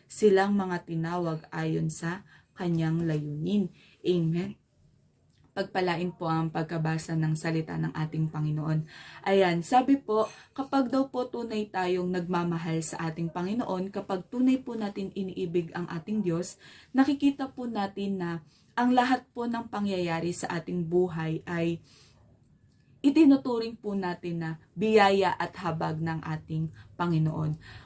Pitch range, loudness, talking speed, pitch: 160-205 Hz, -29 LUFS, 130 wpm, 175 Hz